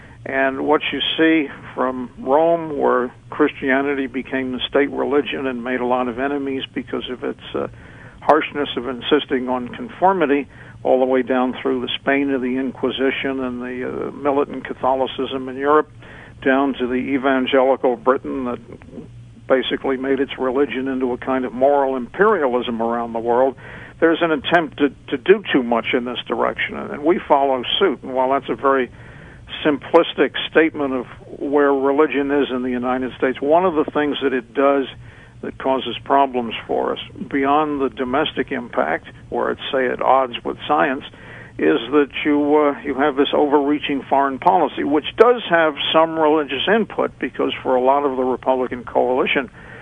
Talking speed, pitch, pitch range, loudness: 170 wpm, 135 Hz, 125-145 Hz, -19 LUFS